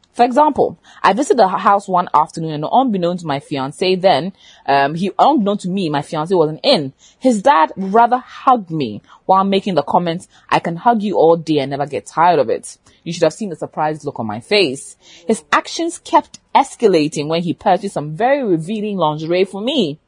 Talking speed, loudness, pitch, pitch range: 200 wpm, -16 LUFS, 180 Hz, 150-215 Hz